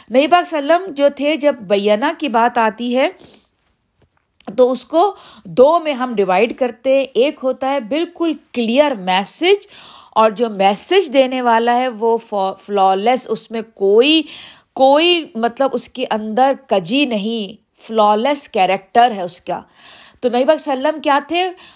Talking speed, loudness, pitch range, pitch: 150 wpm, -16 LUFS, 225-295 Hz, 255 Hz